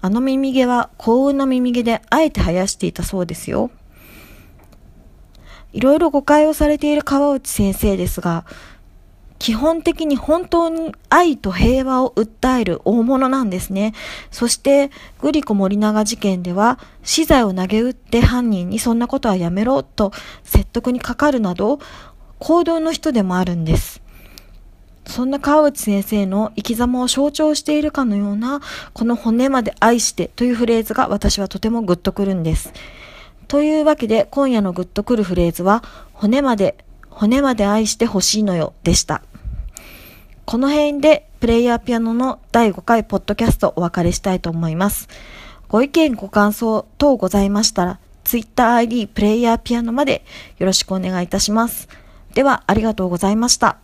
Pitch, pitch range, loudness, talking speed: 225 Hz, 195-265 Hz, -17 LUFS, 335 characters per minute